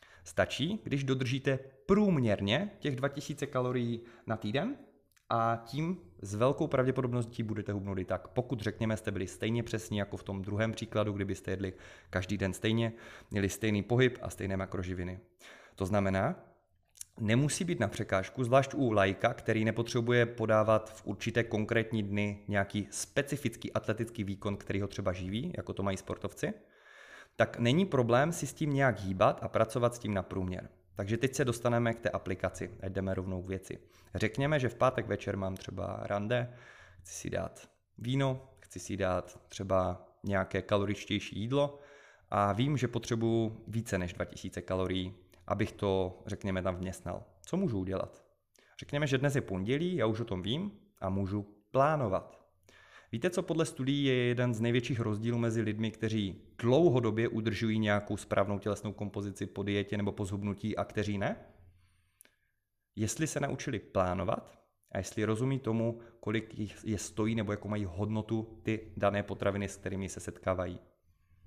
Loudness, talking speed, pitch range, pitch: -33 LUFS, 160 wpm, 95-120 Hz, 105 Hz